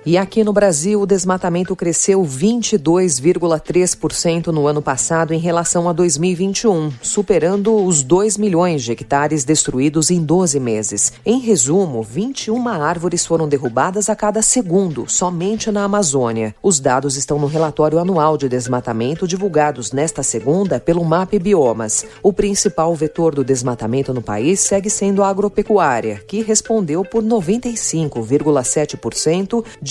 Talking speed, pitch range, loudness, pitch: 135 wpm, 145-200 Hz, -16 LUFS, 170 Hz